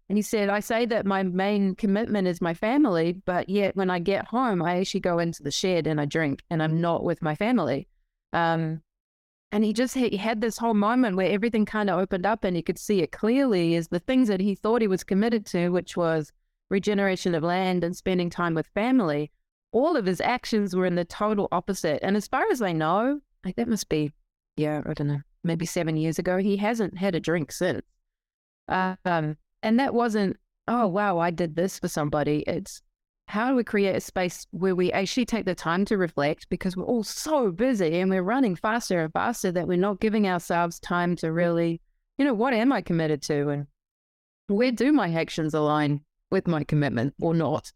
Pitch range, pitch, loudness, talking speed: 165-215 Hz, 185 Hz, -25 LUFS, 215 wpm